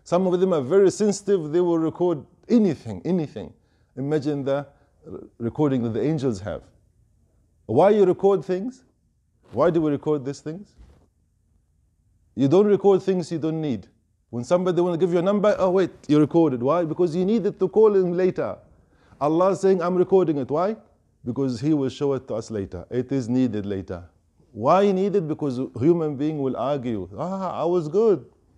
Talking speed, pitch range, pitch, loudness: 180 wpm, 115-185 Hz, 150 Hz, -22 LUFS